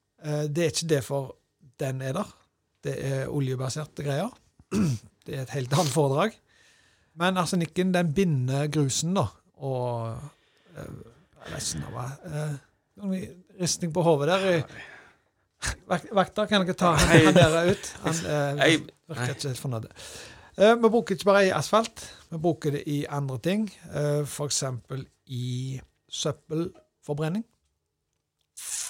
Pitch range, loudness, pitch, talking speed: 140-180 Hz, -26 LUFS, 150 Hz, 125 wpm